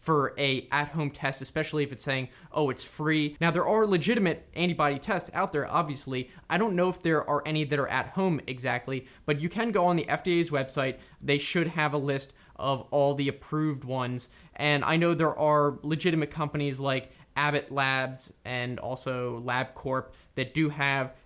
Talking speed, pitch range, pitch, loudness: 185 wpm, 130-160 Hz, 145 Hz, -28 LUFS